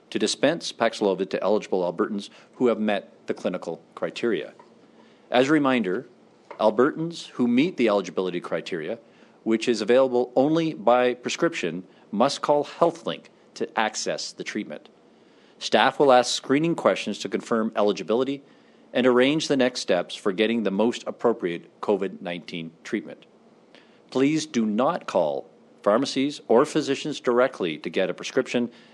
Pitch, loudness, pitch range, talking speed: 125 Hz, -24 LUFS, 110-140 Hz, 140 wpm